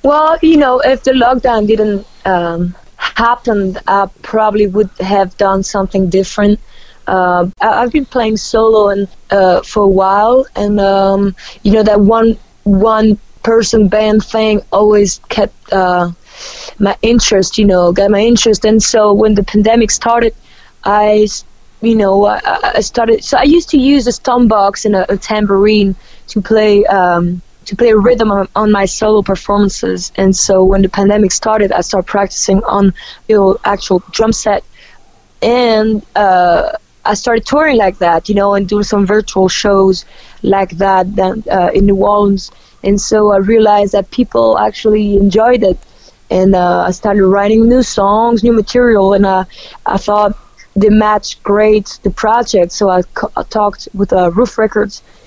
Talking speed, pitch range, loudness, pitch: 170 wpm, 195-225 Hz, -11 LUFS, 205 Hz